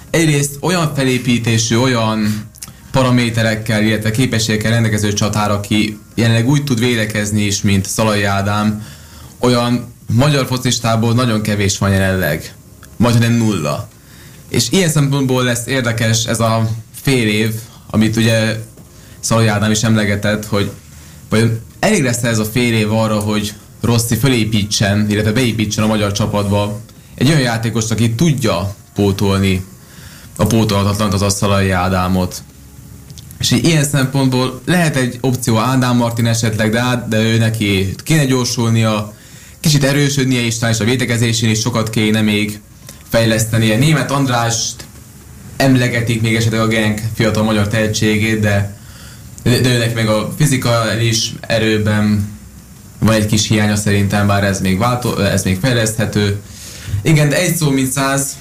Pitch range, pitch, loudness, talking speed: 105-125 Hz, 110 Hz, -15 LUFS, 140 wpm